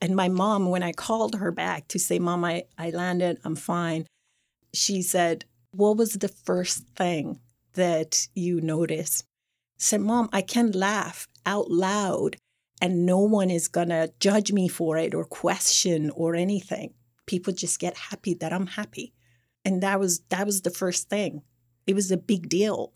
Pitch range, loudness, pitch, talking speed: 165-195 Hz, -25 LUFS, 180 Hz, 175 wpm